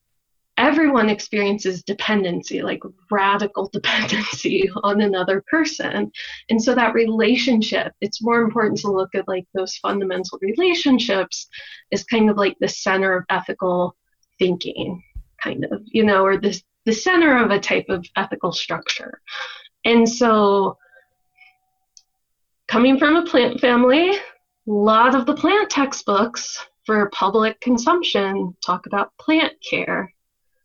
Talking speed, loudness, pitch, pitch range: 130 wpm, -19 LUFS, 220 Hz, 195-265 Hz